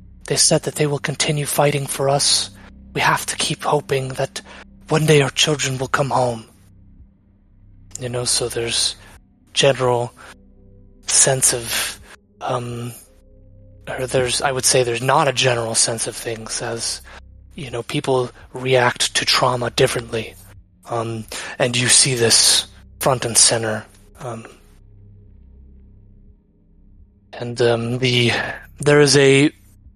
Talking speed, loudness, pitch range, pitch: 130 wpm, -17 LUFS, 100-130 Hz, 115 Hz